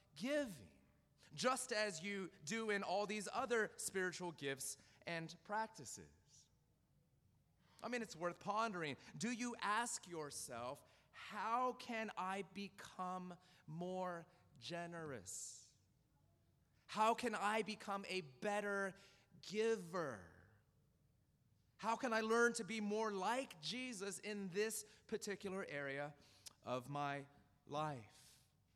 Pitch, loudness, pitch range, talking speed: 185 Hz, -44 LUFS, 145-215 Hz, 105 wpm